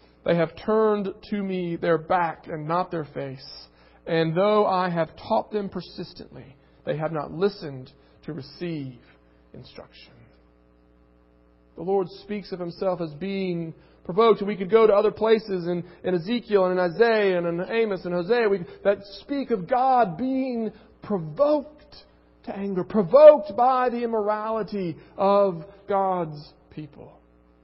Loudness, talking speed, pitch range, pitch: -23 LUFS, 145 wpm, 160-210 Hz, 185 Hz